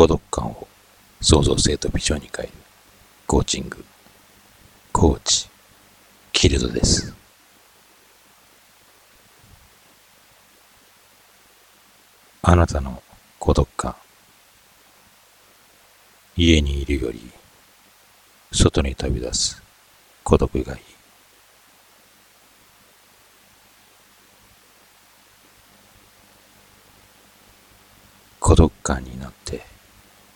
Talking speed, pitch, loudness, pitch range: 115 characters per minute, 95 Hz, -21 LUFS, 85-105 Hz